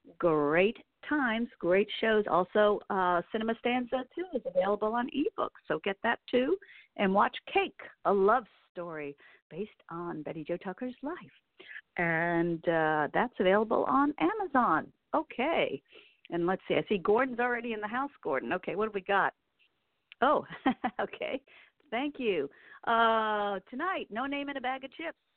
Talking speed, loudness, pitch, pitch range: 155 wpm, -30 LUFS, 225 Hz, 185-265 Hz